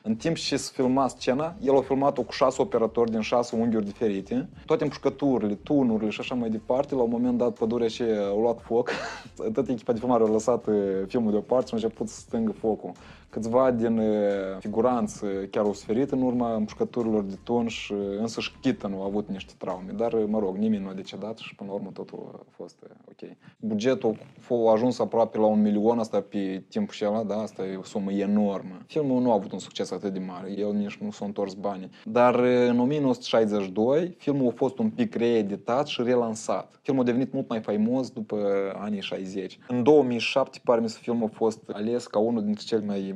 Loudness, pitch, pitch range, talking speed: -26 LUFS, 115 Hz, 105-130 Hz, 210 wpm